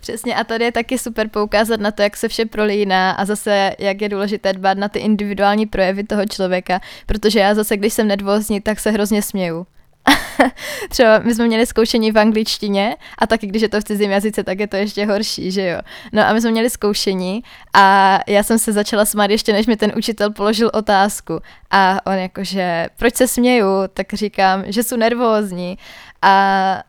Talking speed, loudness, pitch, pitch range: 195 wpm, -16 LUFS, 210 Hz, 195-225 Hz